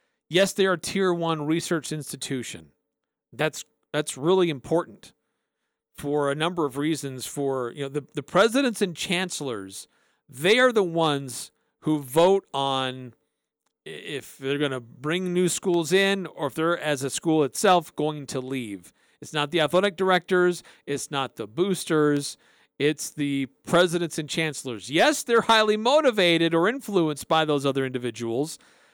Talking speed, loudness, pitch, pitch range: 150 wpm, -24 LUFS, 155 Hz, 135-180 Hz